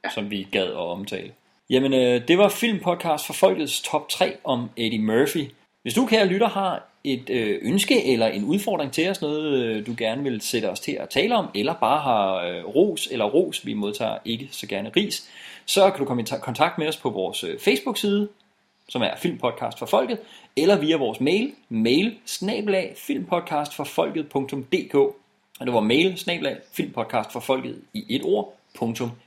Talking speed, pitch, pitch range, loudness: 165 wpm, 155 Hz, 125-205 Hz, -23 LUFS